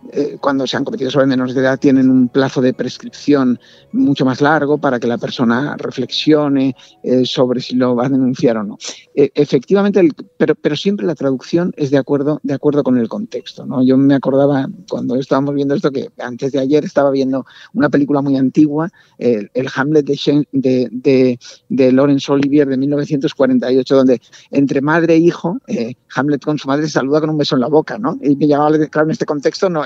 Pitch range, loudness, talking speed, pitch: 130-150 Hz, -15 LUFS, 200 wpm, 140 Hz